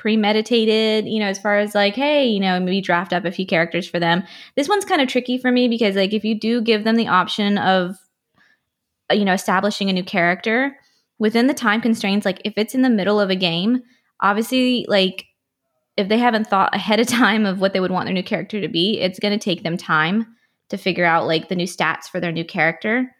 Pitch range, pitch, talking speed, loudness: 185-225 Hz, 205 Hz, 235 wpm, -19 LUFS